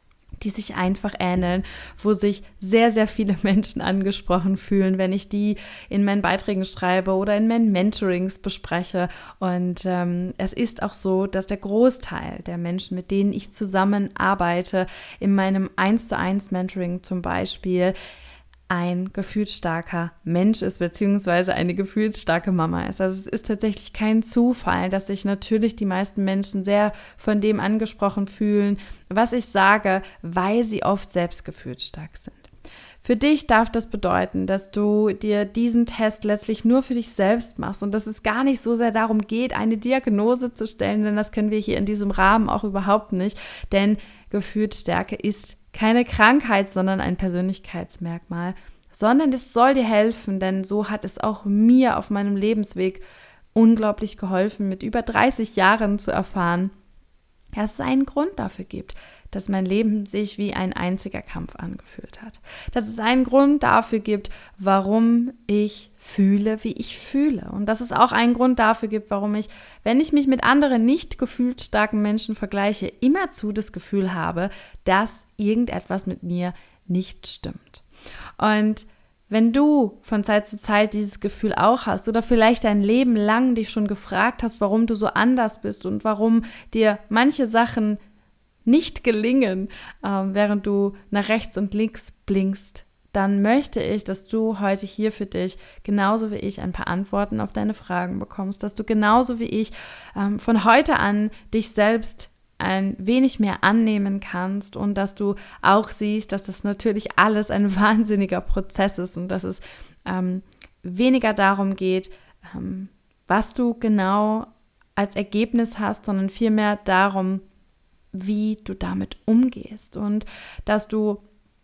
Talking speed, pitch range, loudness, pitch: 160 wpm, 195-220 Hz, -22 LUFS, 210 Hz